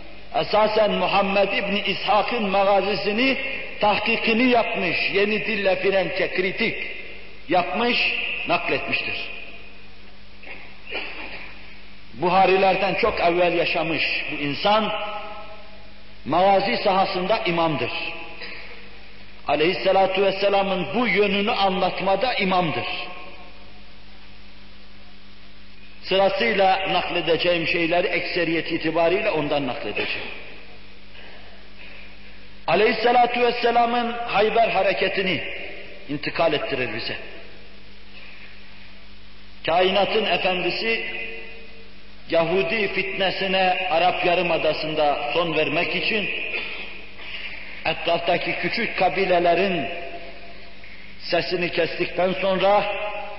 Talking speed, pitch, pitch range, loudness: 65 wpm, 180 Hz, 145-200 Hz, -21 LUFS